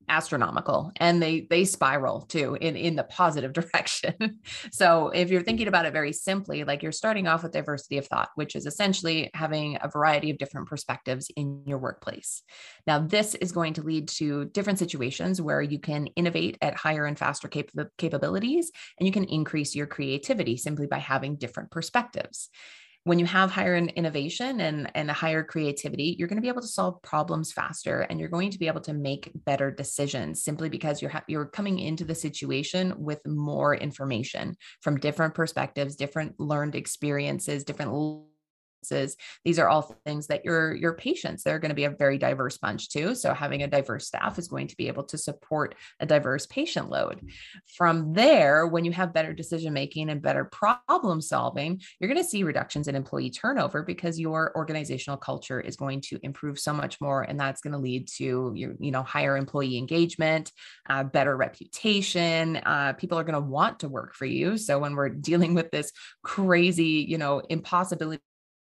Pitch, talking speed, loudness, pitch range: 155 Hz, 190 wpm, -27 LUFS, 145-170 Hz